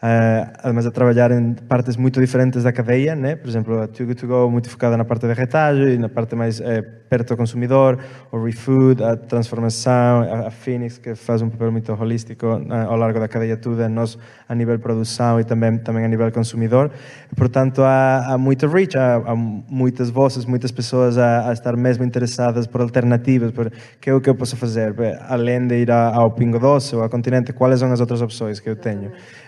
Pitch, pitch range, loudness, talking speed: 120 Hz, 115-125 Hz, -18 LUFS, 205 wpm